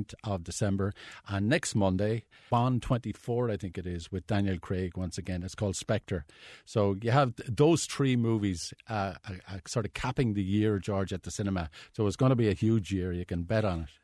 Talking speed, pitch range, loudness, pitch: 210 wpm, 95-115 Hz, -31 LUFS, 100 Hz